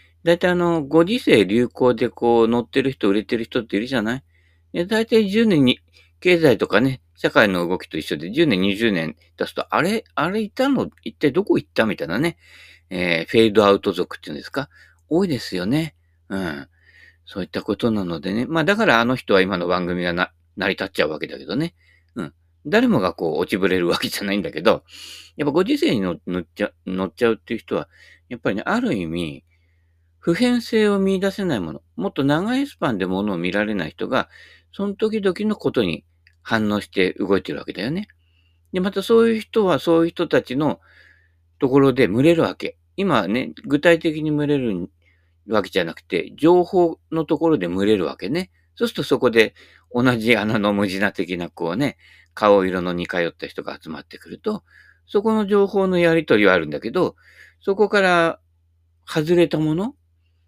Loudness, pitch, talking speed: -20 LUFS, 115 Hz, 360 characters per minute